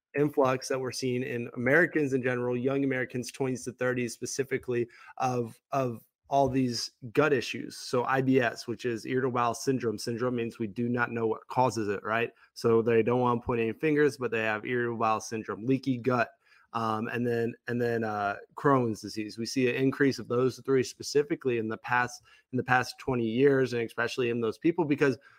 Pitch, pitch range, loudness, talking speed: 125 Hz, 115-130 Hz, -29 LUFS, 195 wpm